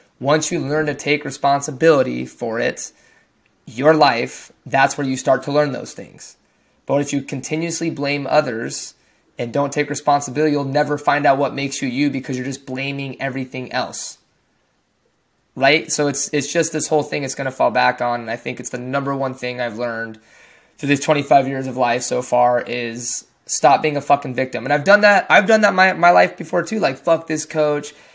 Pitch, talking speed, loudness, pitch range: 140 Hz, 205 wpm, -18 LUFS, 130-150 Hz